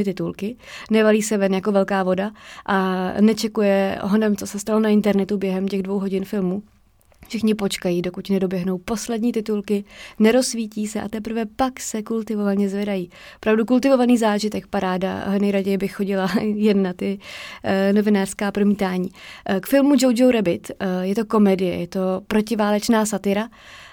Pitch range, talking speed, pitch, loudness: 195-220 Hz, 150 wpm, 205 Hz, -21 LUFS